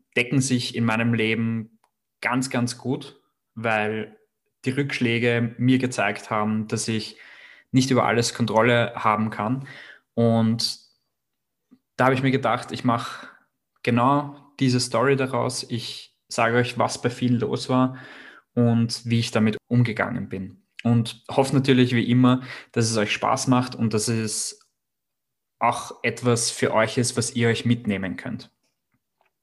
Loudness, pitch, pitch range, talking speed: -23 LUFS, 120 Hz, 115-125 Hz, 145 wpm